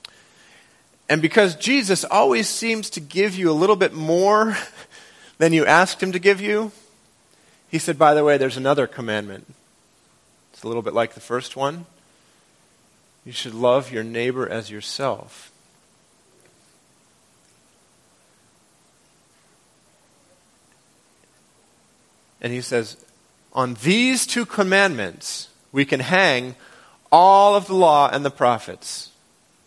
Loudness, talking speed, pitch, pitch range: -19 LUFS, 120 wpm, 155 Hz, 125-200 Hz